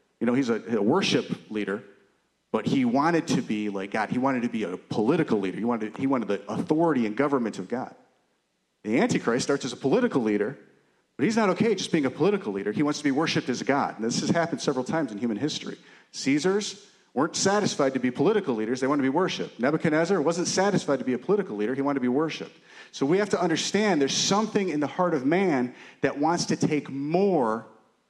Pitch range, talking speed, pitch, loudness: 120-195 Hz, 230 wpm, 150 Hz, -26 LUFS